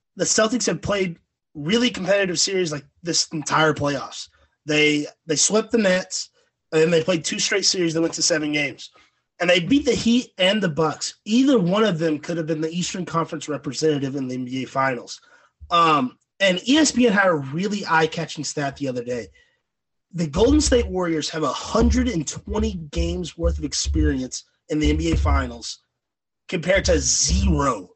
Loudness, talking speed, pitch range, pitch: -21 LUFS, 175 wpm, 145-200 Hz, 165 Hz